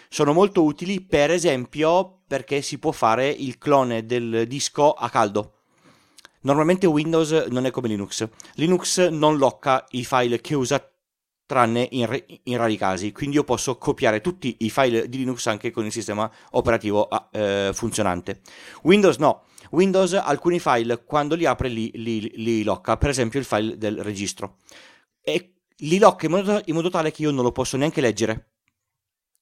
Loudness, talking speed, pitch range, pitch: -22 LUFS, 170 wpm, 115-155 Hz, 130 Hz